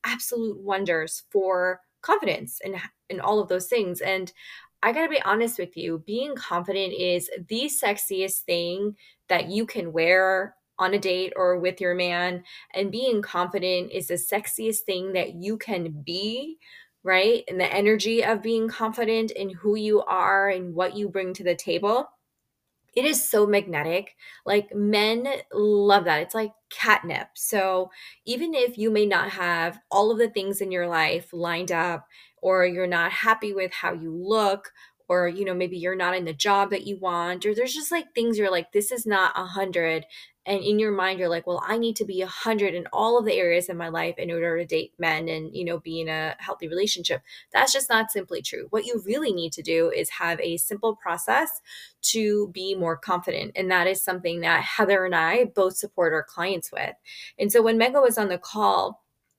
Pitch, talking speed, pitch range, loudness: 195 Hz, 200 wpm, 175-215 Hz, -24 LUFS